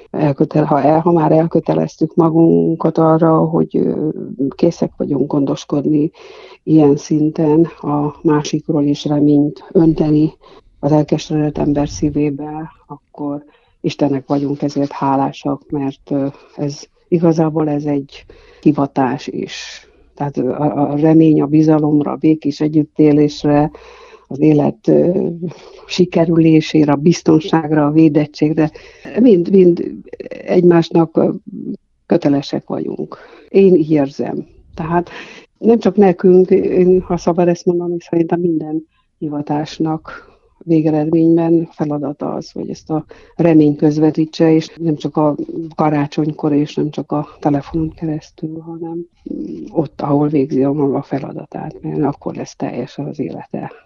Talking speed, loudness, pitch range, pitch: 115 wpm, -15 LUFS, 145-165 Hz, 155 Hz